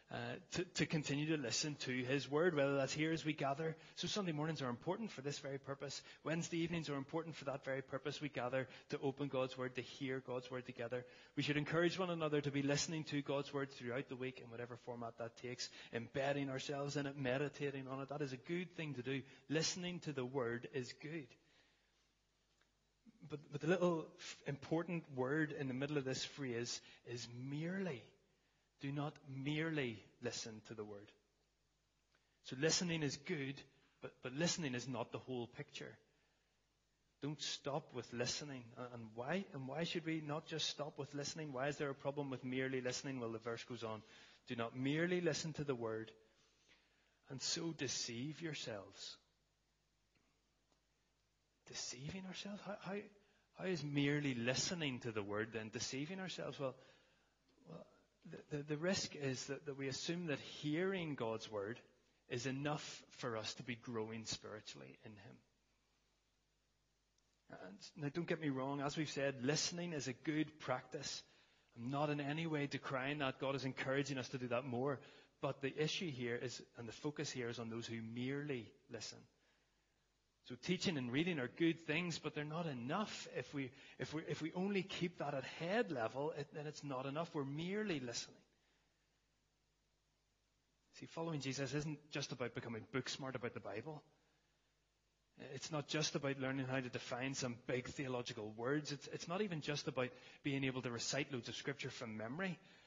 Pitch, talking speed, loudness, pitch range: 140 Hz, 180 wpm, -43 LUFS, 125-155 Hz